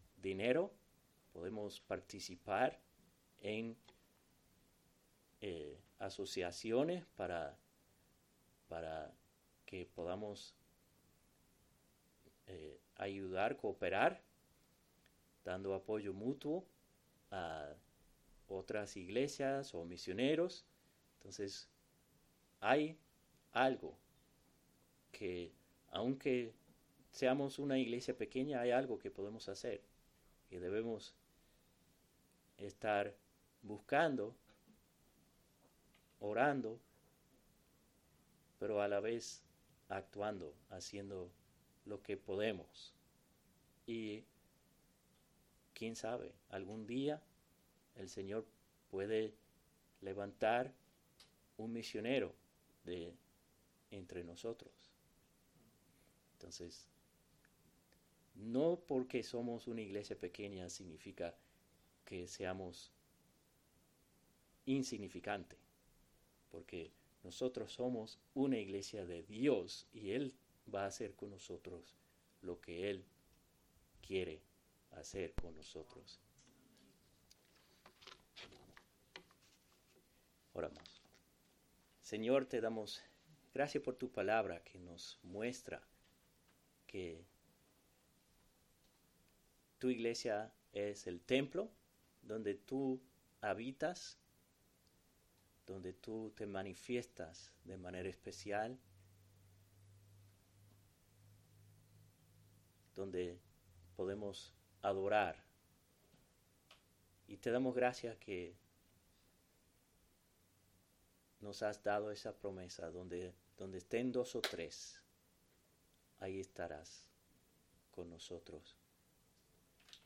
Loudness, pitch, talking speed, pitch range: -43 LUFS, 100 Hz, 70 wpm, 90-115 Hz